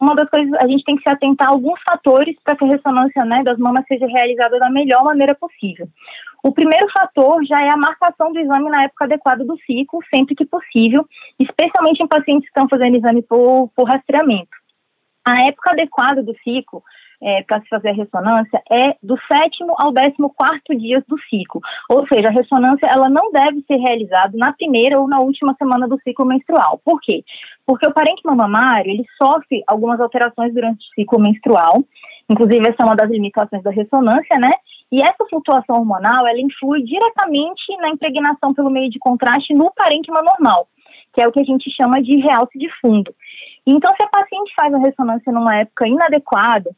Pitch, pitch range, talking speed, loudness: 270 Hz, 240-300 Hz, 190 wpm, -14 LUFS